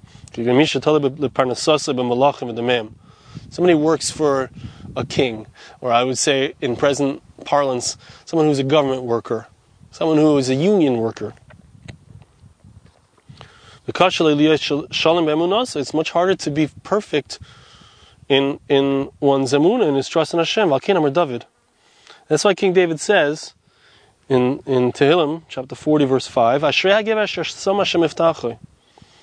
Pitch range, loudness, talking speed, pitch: 125-160 Hz, -18 LUFS, 105 wpm, 145 Hz